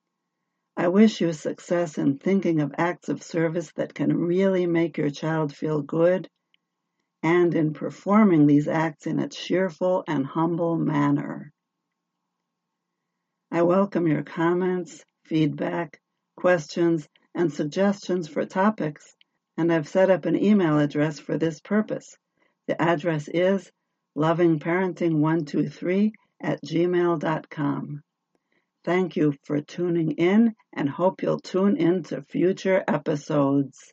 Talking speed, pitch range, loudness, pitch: 120 wpm, 155-185 Hz, -24 LUFS, 170 Hz